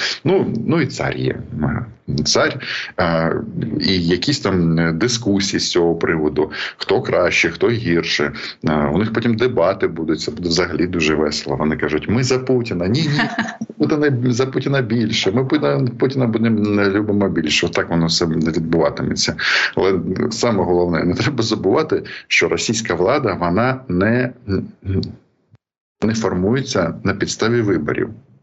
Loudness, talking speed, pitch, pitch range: -18 LUFS, 135 wpm, 100 Hz, 85-125 Hz